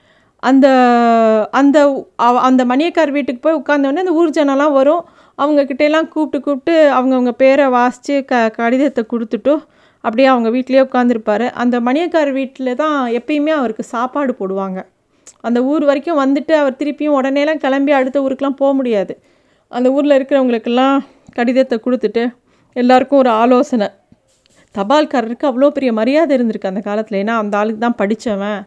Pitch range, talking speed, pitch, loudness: 240-285 Hz, 135 wpm, 265 Hz, -14 LUFS